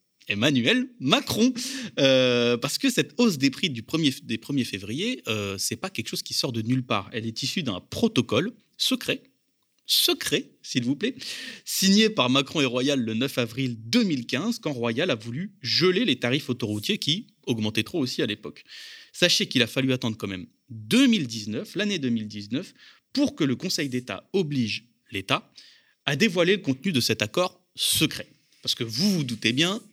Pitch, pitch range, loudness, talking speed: 135 Hz, 120-195 Hz, -25 LUFS, 180 wpm